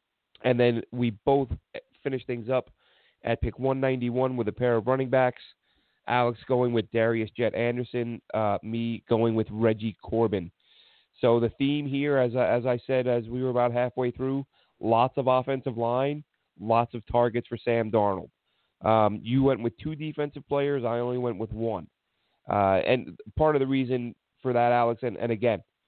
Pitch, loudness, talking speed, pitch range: 120 Hz, -27 LUFS, 175 wpm, 115-130 Hz